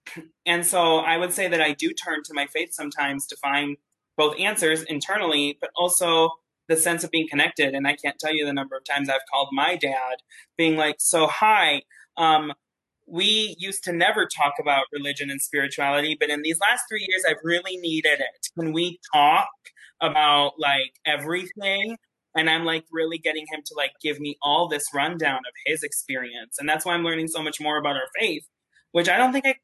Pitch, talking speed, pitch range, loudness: 160 Hz, 200 wpm, 145-175 Hz, -23 LUFS